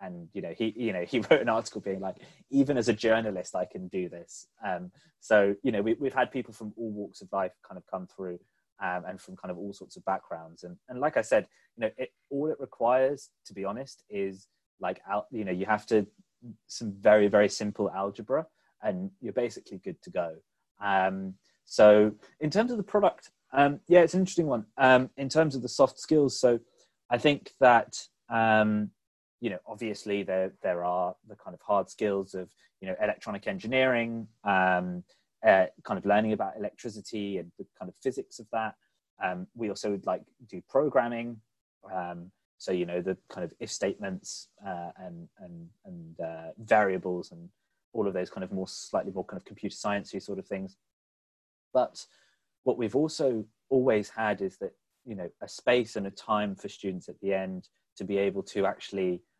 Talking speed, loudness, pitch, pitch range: 200 wpm, -29 LUFS, 105 Hz, 95-130 Hz